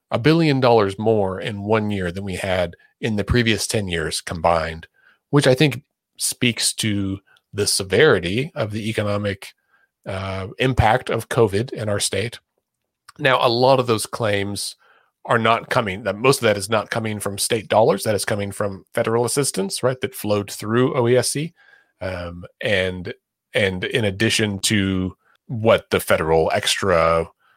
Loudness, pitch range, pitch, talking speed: -20 LUFS, 95-120 Hz, 105 Hz, 160 wpm